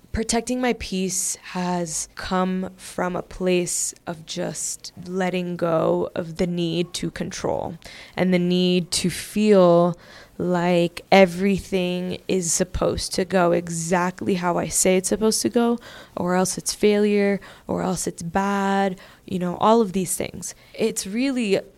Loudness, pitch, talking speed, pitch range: -22 LUFS, 185 Hz, 145 wpm, 175-195 Hz